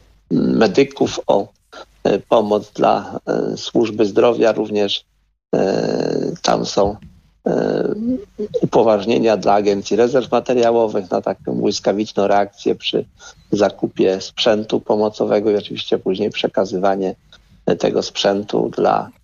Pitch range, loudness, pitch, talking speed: 100-115 Hz, -18 LUFS, 105 Hz, 90 wpm